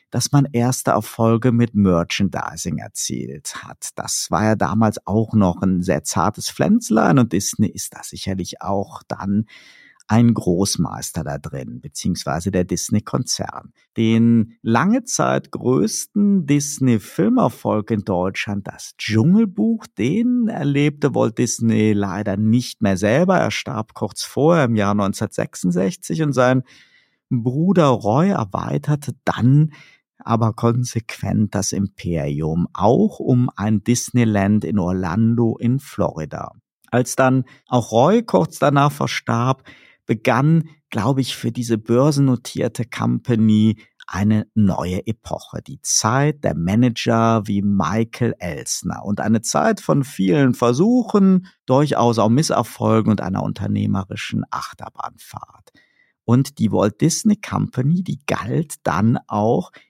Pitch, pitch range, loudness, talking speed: 115 Hz, 105-140 Hz, -19 LUFS, 120 wpm